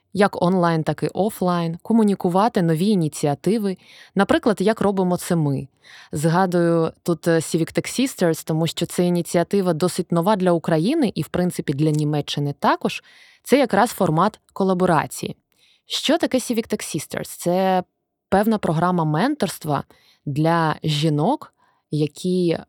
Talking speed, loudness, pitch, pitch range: 125 wpm, -21 LUFS, 180 Hz, 165-200 Hz